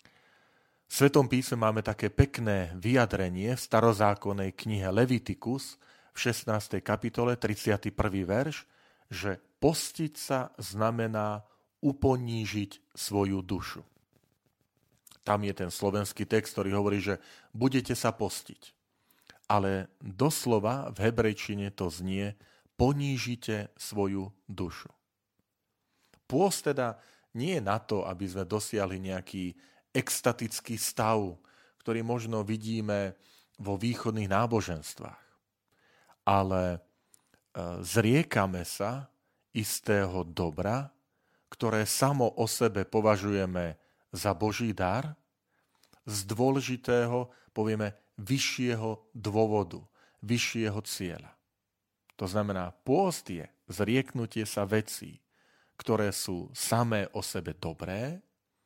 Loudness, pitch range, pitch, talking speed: -31 LUFS, 100-120 Hz, 110 Hz, 95 wpm